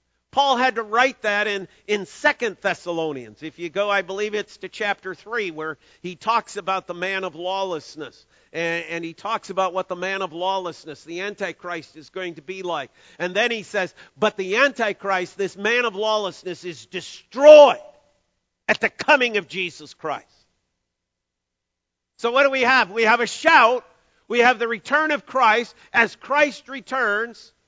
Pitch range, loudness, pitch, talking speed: 175-230 Hz, -20 LUFS, 195 Hz, 175 wpm